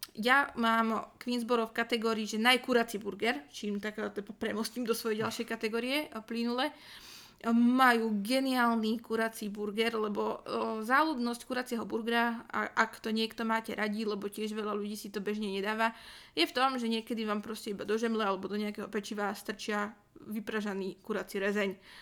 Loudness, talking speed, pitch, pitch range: -32 LUFS, 155 wpm, 225 Hz, 210-235 Hz